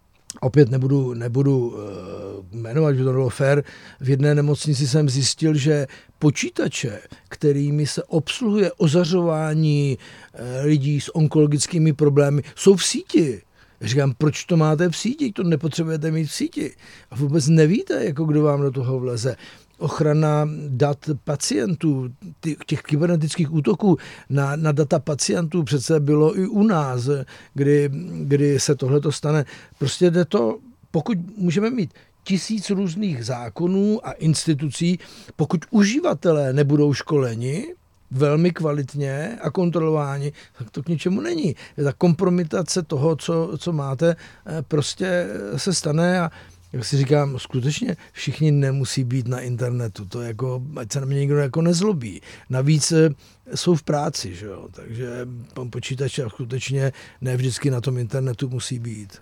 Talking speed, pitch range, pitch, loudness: 140 wpm, 130-165 Hz, 145 Hz, -21 LUFS